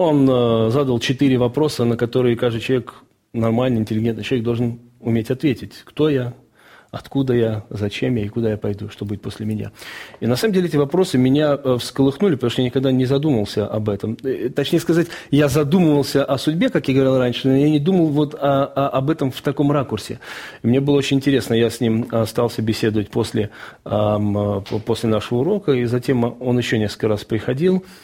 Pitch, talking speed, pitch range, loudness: 125 Hz, 185 wpm, 110-140 Hz, -19 LUFS